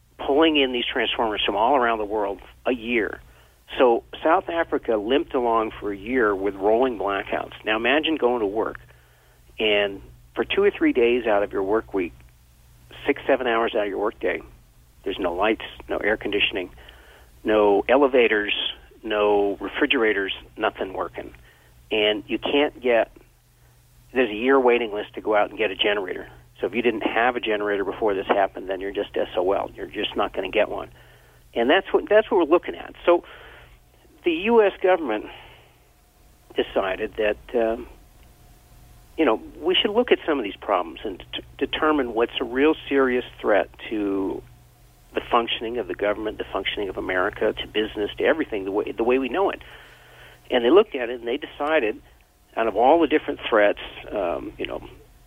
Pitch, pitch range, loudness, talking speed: 110 Hz, 100-135 Hz, -23 LUFS, 180 wpm